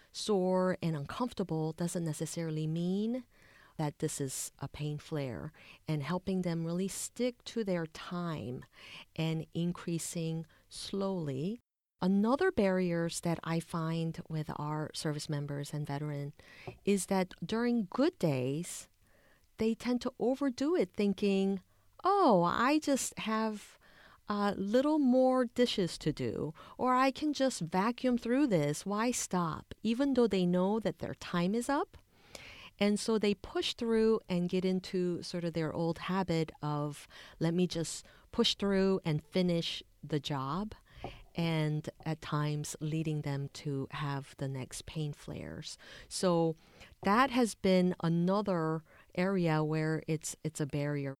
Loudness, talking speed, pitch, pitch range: -33 LUFS, 140 wpm, 175 Hz, 155-210 Hz